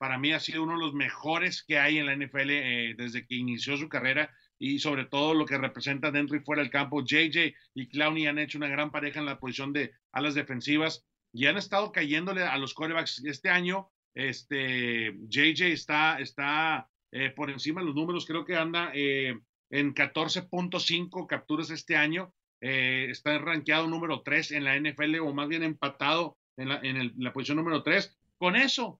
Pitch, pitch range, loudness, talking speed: 150 Hz, 135-160 Hz, -29 LUFS, 200 wpm